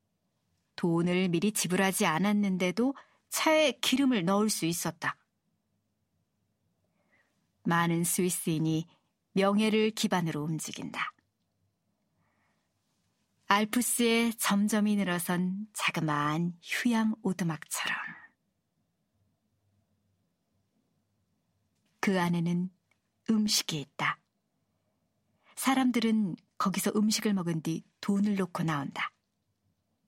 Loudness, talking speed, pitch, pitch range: -29 LUFS, 185 characters per minute, 185 Hz, 165-215 Hz